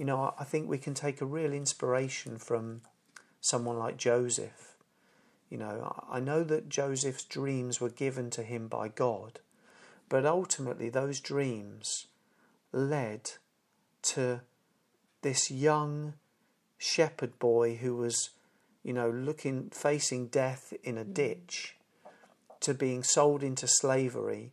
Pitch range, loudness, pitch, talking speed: 120-140 Hz, -32 LUFS, 130 Hz, 125 wpm